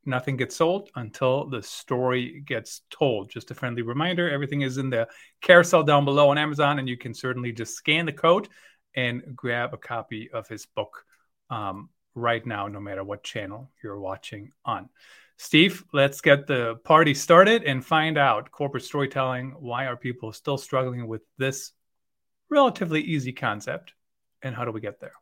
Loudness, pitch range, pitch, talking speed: -24 LUFS, 120-145 Hz, 130 Hz, 175 wpm